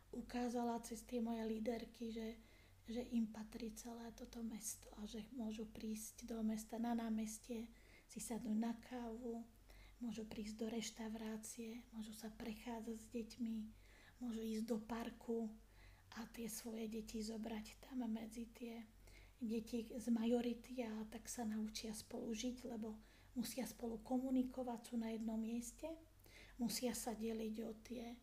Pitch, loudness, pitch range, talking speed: 230 Hz, -47 LUFS, 225-235 Hz, 140 wpm